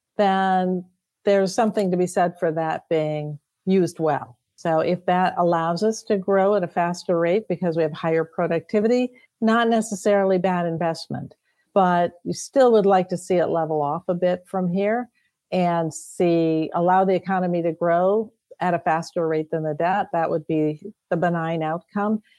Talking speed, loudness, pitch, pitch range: 175 wpm, -22 LUFS, 180 Hz, 165-195 Hz